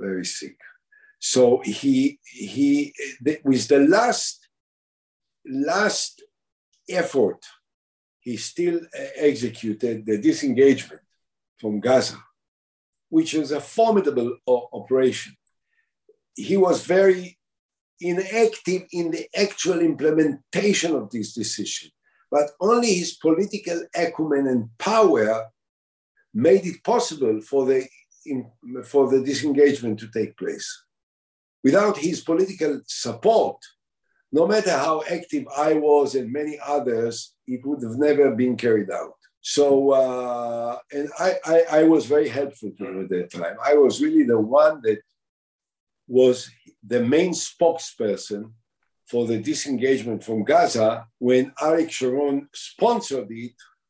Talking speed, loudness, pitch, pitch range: 120 wpm, -22 LUFS, 145 Hz, 125-185 Hz